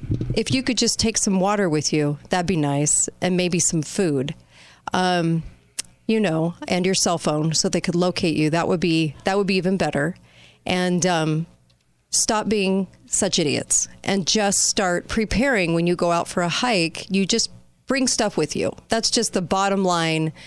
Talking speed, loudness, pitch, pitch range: 190 wpm, -21 LUFS, 180 Hz, 160-200 Hz